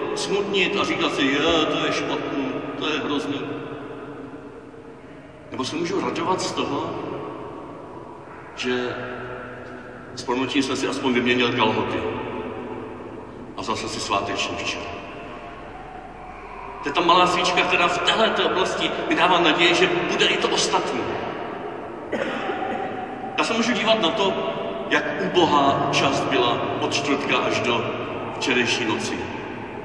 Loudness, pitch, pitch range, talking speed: -22 LUFS, 140 Hz, 120-175 Hz, 125 wpm